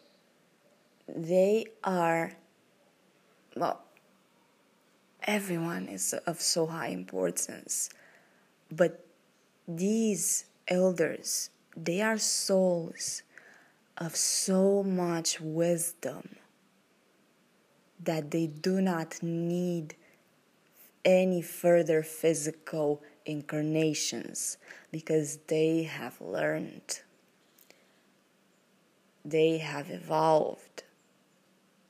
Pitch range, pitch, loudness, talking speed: 160-185 Hz, 170 Hz, -30 LUFS, 65 wpm